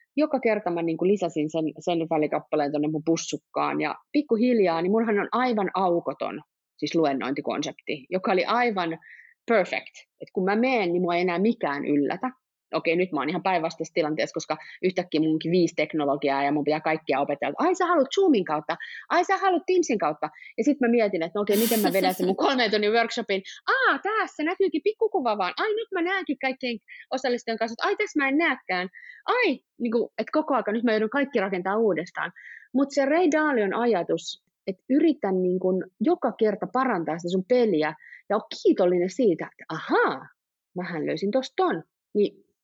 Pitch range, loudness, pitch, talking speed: 170-265 Hz, -25 LUFS, 210 Hz, 185 wpm